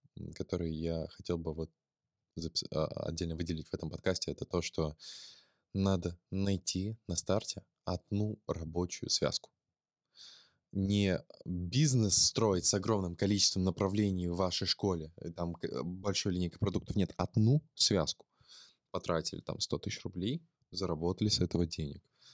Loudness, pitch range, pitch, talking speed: -34 LUFS, 85-100 Hz, 95 Hz, 125 wpm